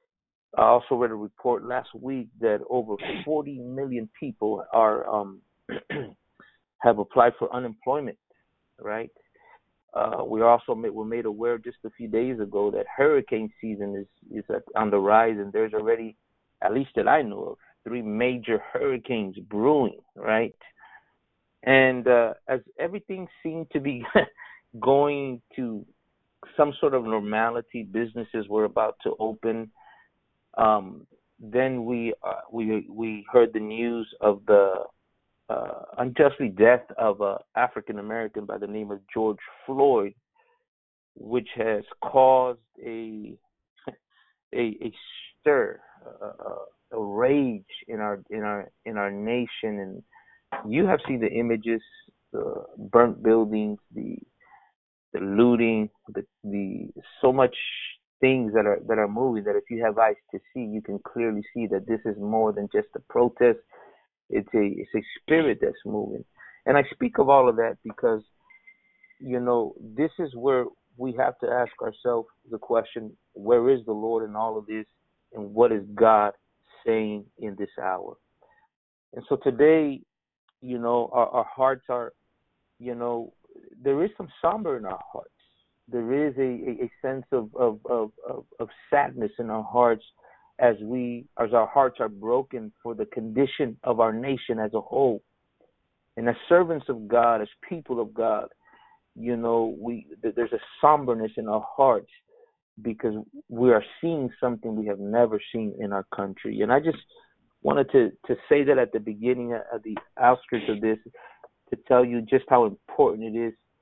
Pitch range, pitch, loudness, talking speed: 110-135 Hz, 120 Hz, -25 LUFS, 155 wpm